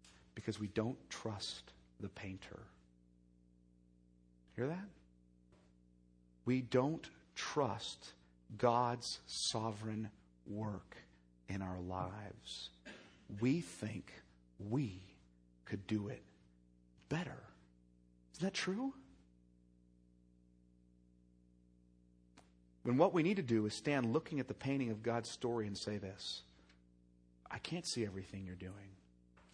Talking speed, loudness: 105 wpm, -41 LUFS